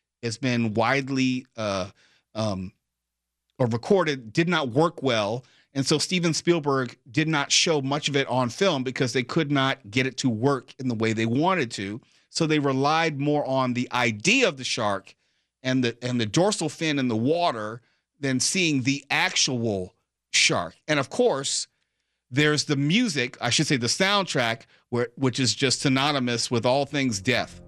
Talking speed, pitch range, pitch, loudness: 175 wpm, 115-150 Hz, 130 Hz, -24 LUFS